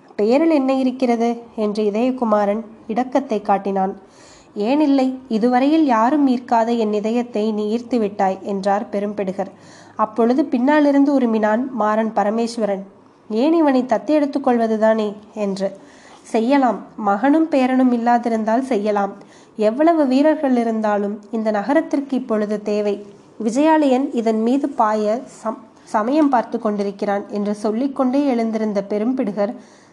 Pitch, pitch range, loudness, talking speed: 230 Hz, 210-265 Hz, -19 LUFS, 105 wpm